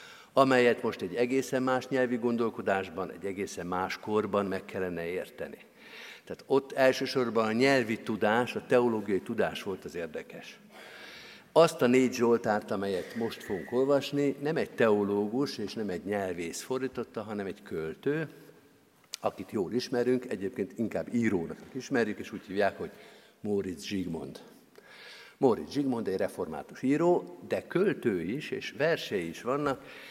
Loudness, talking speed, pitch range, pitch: -30 LUFS, 140 wpm, 105-135 Hz, 125 Hz